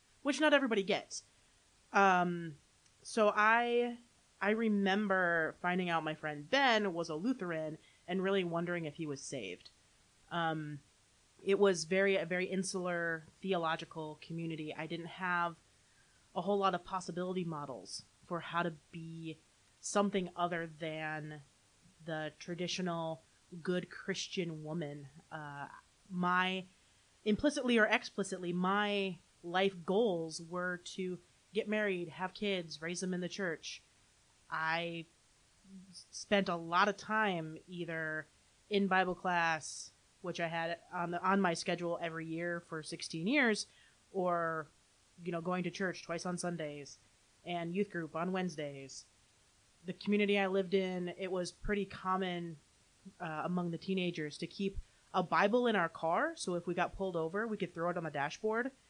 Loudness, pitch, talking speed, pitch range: -36 LUFS, 175 Hz, 145 wpm, 160-190 Hz